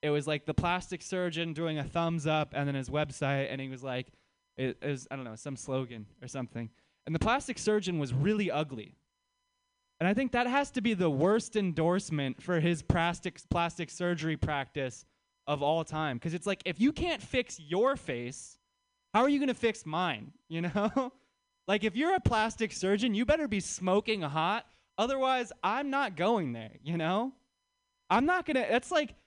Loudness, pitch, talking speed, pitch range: -31 LUFS, 180 Hz, 195 wpm, 150-245 Hz